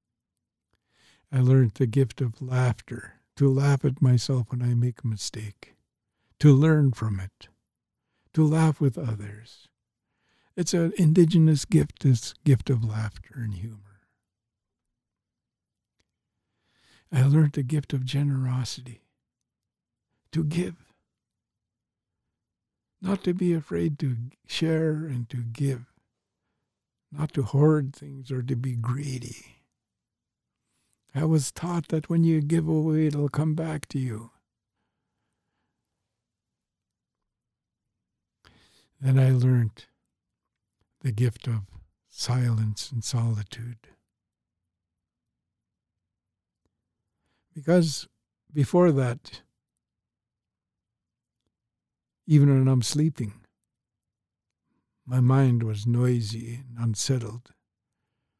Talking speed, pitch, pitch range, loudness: 95 wpm, 120 Hz, 110-140 Hz, -25 LUFS